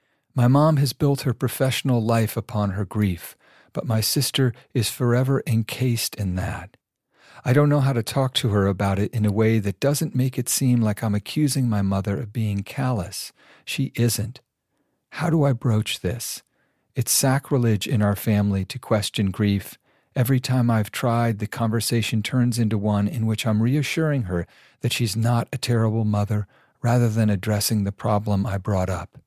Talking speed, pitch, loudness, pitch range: 180 wpm, 115 Hz, -22 LUFS, 105-130 Hz